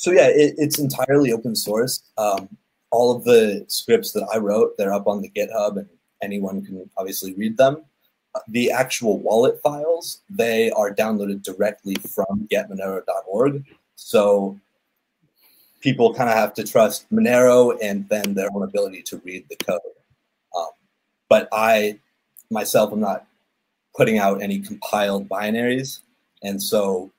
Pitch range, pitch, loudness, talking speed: 100-165 Hz, 120 Hz, -20 LUFS, 145 wpm